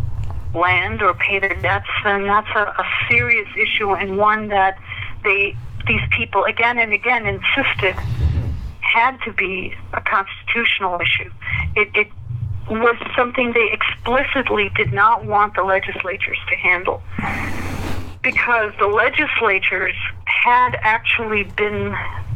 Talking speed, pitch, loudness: 125 wpm, 195 Hz, -17 LUFS